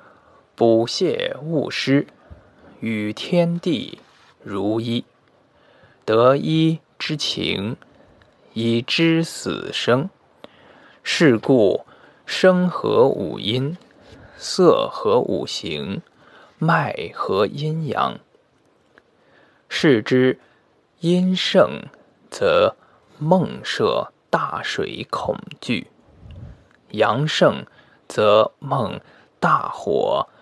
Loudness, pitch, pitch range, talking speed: -20 LUFS, 160 Hz, 120-180 Hz, 95 characters per minute